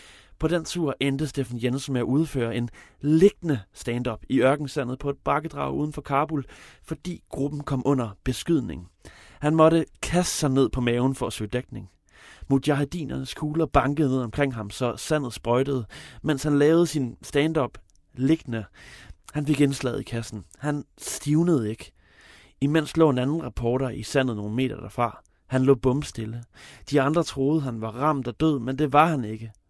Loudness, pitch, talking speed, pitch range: -25 LUFS, 135 Hz, 170 wpm, 120-150 Hz